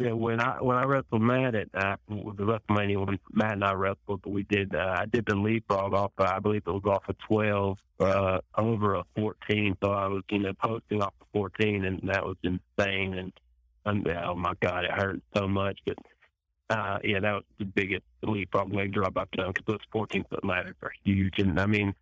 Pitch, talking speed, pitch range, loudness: 100 Hz, 230 wpm, 95-105 Hz, -29 LUFS